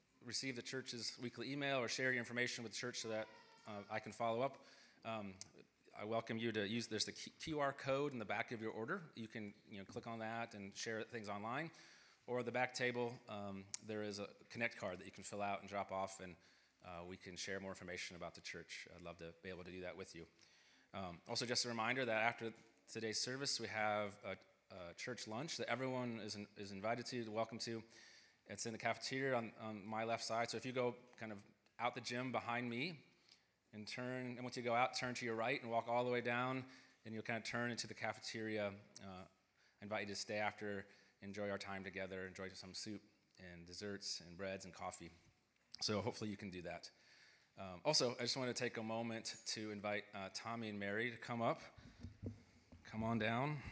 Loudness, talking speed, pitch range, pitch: -44 LUFS, 225 wpm, 100-120 Hz, 110 Hz